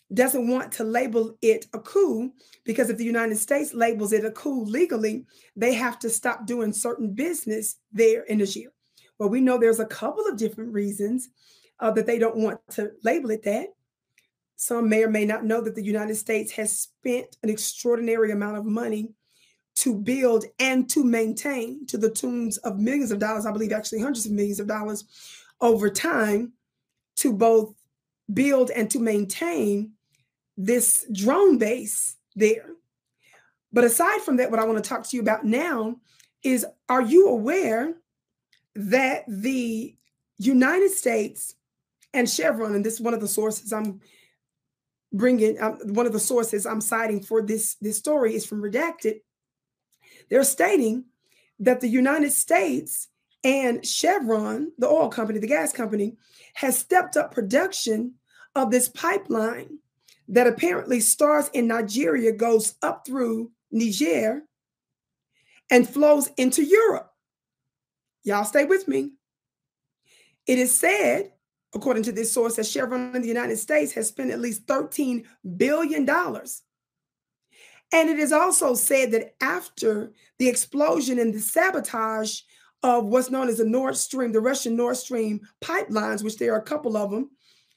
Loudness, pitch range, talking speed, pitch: -23 LUFS, 215-260 Hz, 155 wpm, 230 Hz